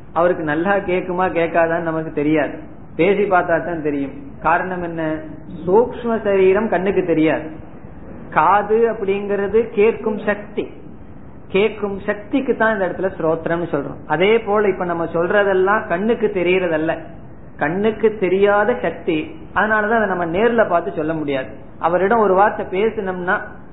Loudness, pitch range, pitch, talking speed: -18 LUFS, 165-210 Hz, 185 Hz, 105 wpm